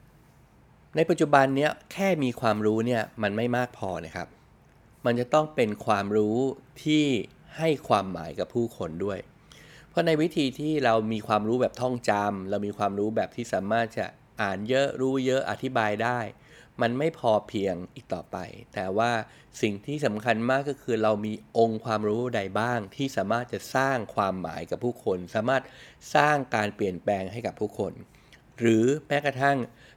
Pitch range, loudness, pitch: 105-135 Hz, -27 LUFS, 120 Hz